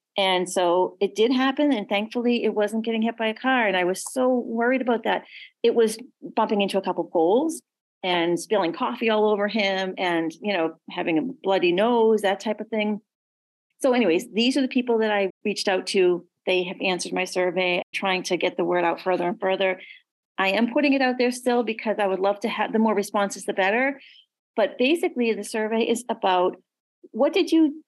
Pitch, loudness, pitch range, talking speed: 210 Hz, -23 LUFS, 185-240 Hz, 210 wpm